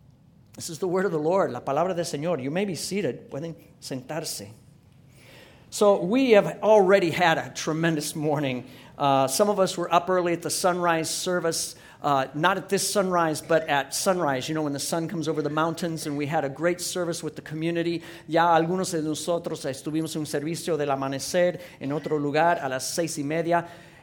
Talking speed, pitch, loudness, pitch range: 200 wpm, 165 Hz, -25 LUFS, 145-175 Hz